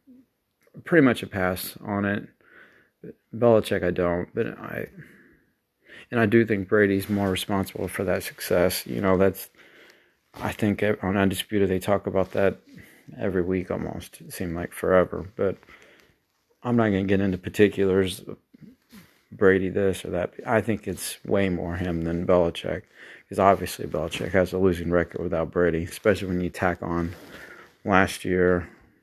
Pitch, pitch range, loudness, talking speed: 95 Hz, 90-100 Hz, -24 LUFS, 155 wpm